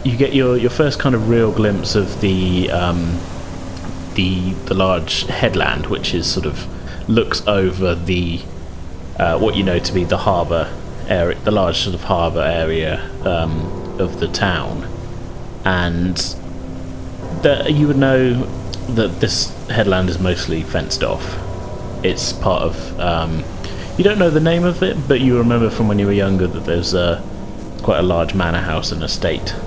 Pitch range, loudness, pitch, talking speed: 85-110 Hz, -18 LUFS, 95 Hz, 170 wpm